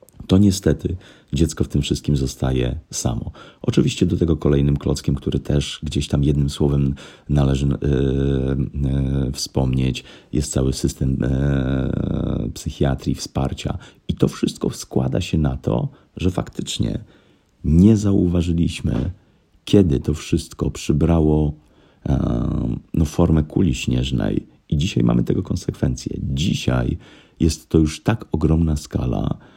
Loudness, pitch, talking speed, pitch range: -21 LUFS, 70 Hz, 125 wpm, 65-80 Hz